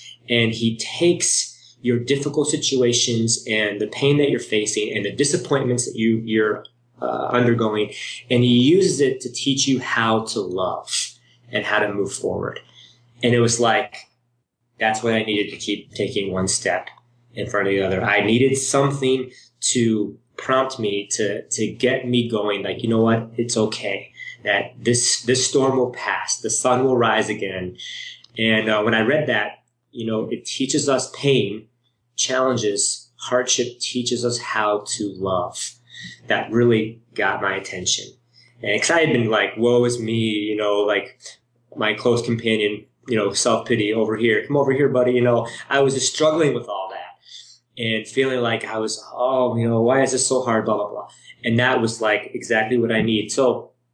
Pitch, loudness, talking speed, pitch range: 120 Hz, -20 LUFS, 180 wpm, 110-125 Hz